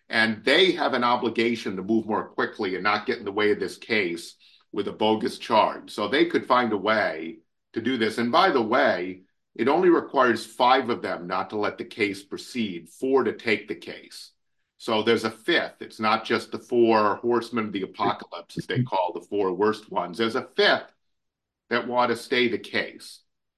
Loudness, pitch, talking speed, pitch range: -24 LUFS, 110 Hz, 205 wpm, 105-120 Hz